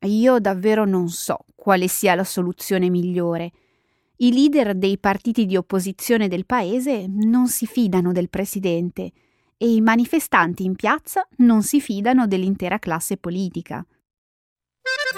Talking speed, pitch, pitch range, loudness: 130 wpm, 195 Hz, 180-235 Hz, -20 LUFS